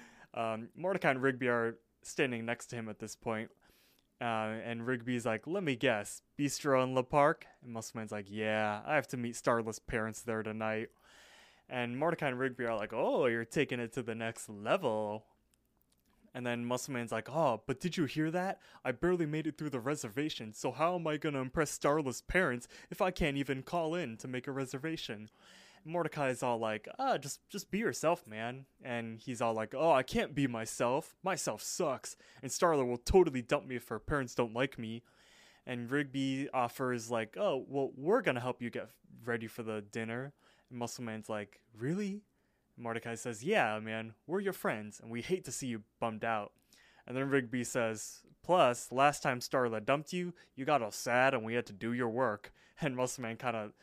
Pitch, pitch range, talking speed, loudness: 125 Hz, 115-145 Hz, 200 wpm, -35 LUFS